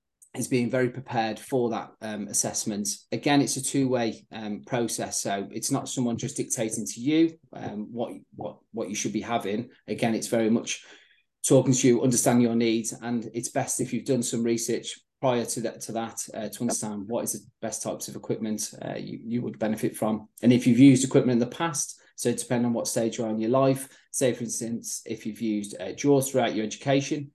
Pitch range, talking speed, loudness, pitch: 110-130 Hz, 215 wpm, -26 LUFS, 120 Hz